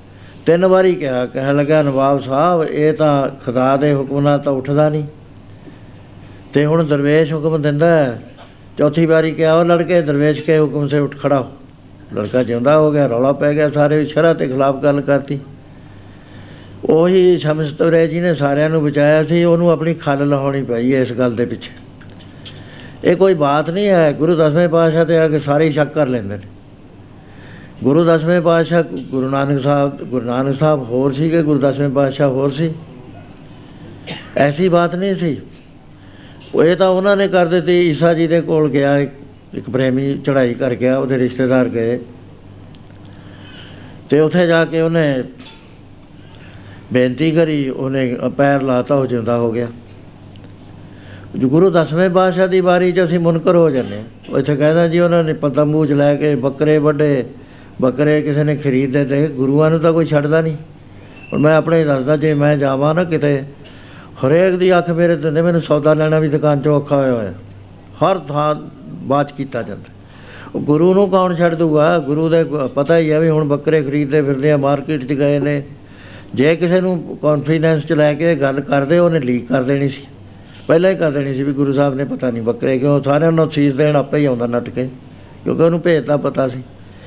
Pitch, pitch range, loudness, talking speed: 145 Hz, 130-160 Hz, -15 LUFS, 175 wpm